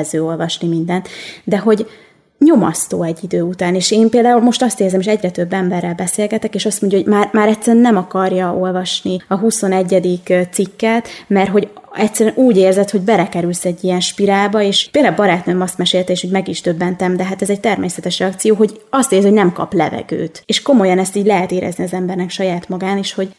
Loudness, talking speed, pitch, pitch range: -14 LUFS, 200 wpm, 190 Hz, 180-215 Hz